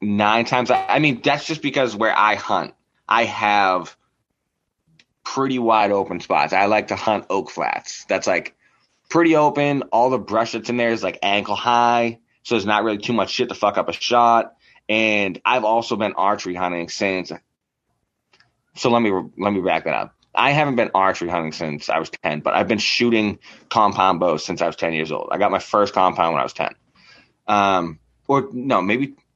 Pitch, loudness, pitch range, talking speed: 110 Hz, -19 LUFS, 95-125 Hz, 200 wpm